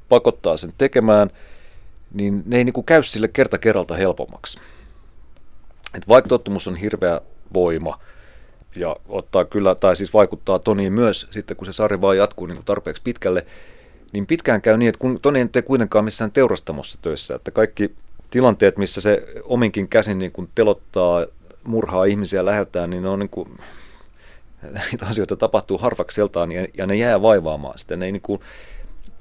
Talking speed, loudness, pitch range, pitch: 155 wpm, -19 LUFS, 95-115 Hz, 105 Hz